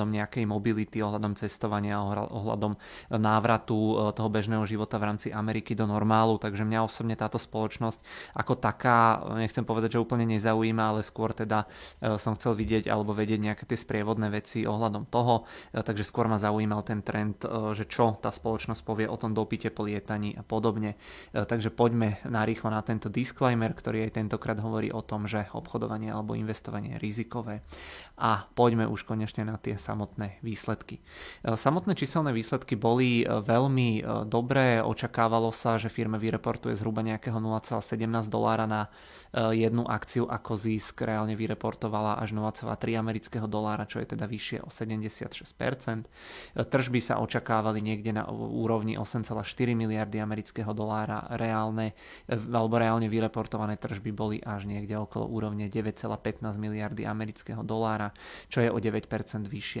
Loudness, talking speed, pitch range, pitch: -30 LUFS, 145 wpm, 105-115 Hz, 110 Hz